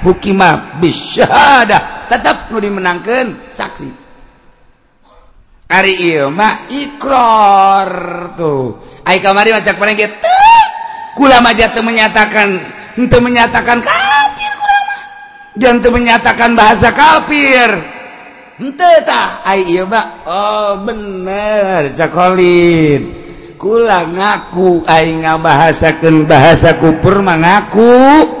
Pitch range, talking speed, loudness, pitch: 180-250 Hz, 85 wpm, -9 LUFS, 215 Hz